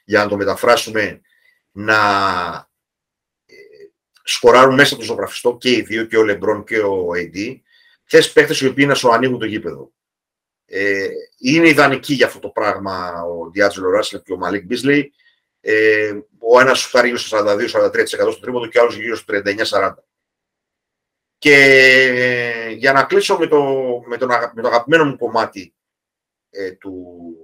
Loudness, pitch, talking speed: -15 LUFS, 135 Hz, 155 wpm